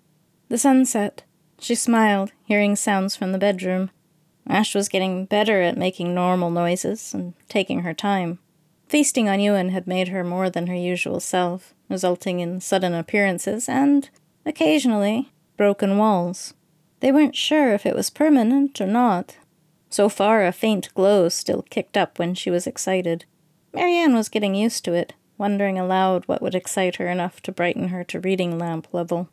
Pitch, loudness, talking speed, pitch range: 190 Hz, -21 LUFS, 170 wpm, 175-215 Hz